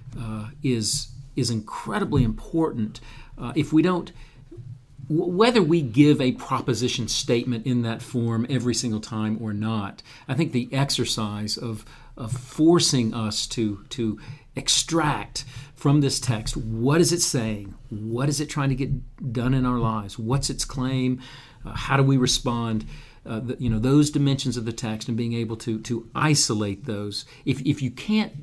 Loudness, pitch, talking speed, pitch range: -24 LUFS, 125 Hz, 170 wpm, 115-140 Hz